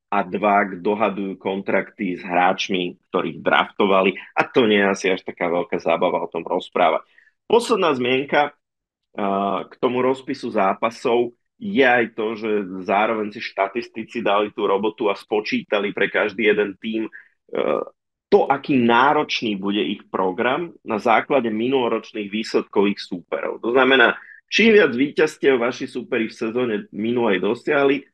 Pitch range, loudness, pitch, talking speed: 100-125 Hz, -20 LUFS, 110 Hz, 140 wpm